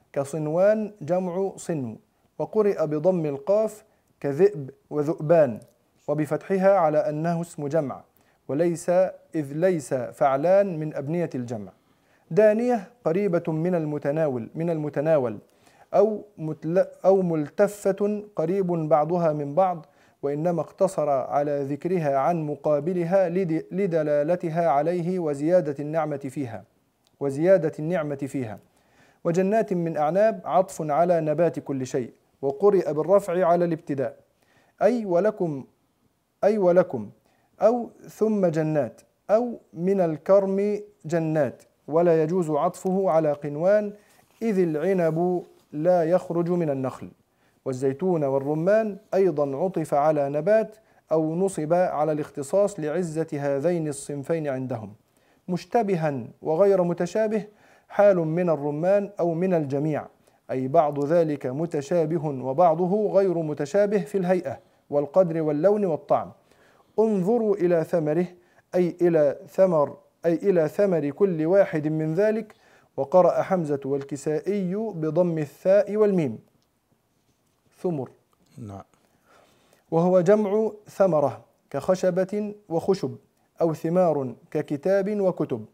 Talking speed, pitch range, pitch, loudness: 105 wpm, 150-190 Hz, 170 Hz, -24 LUFS